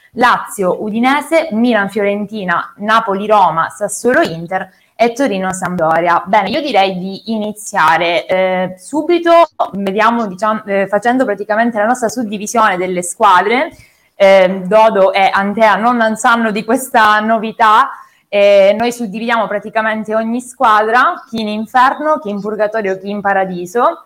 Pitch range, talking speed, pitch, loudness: 195-235 Hz, 130 wpm, 215 Hz, -13 LUFS